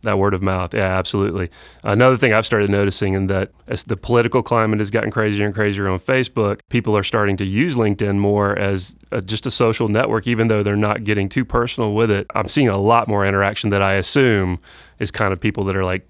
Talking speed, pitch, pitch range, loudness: 230 wpm, 105 Hz, 100-115 Hz, -18 LUFS